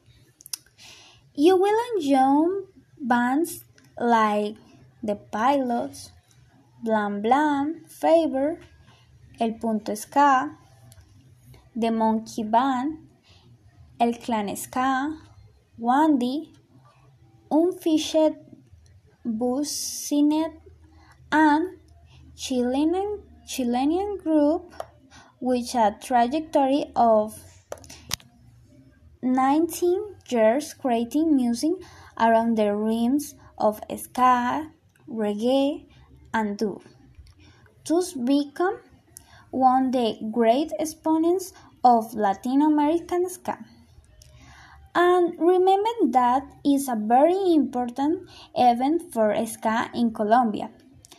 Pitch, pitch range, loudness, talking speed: 255 Hz, 225-310 Hz, -23 LUFS, 75 wpm